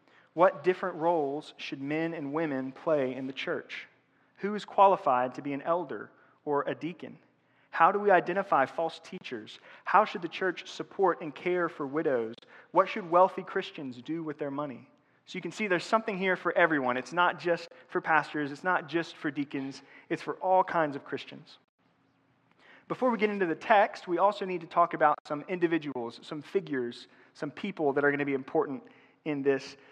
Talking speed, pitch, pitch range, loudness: 190 wpm, 165 Hz, 145-185 Hz, -29 LUFS